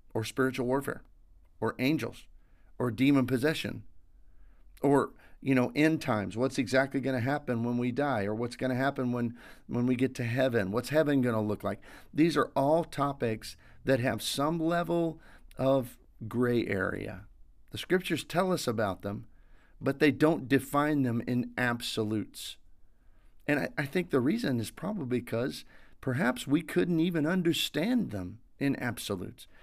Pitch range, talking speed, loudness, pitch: 110-140 Hz, 155 wpm, -30 LUFS, 125 Hz